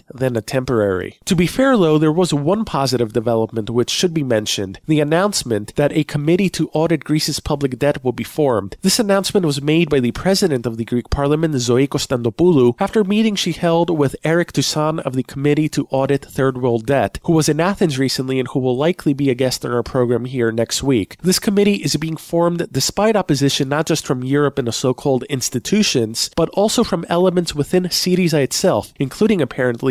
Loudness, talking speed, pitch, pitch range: -17 LUFS, 200 wpm, 145 Hz, 130-170 Hz